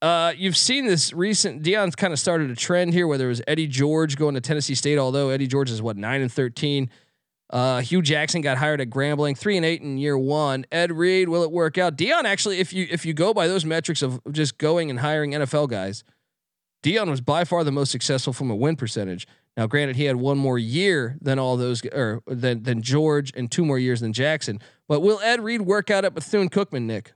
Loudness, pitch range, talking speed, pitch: -22 LUFS, 130-170 Hz, 235 wpm, 150 Hz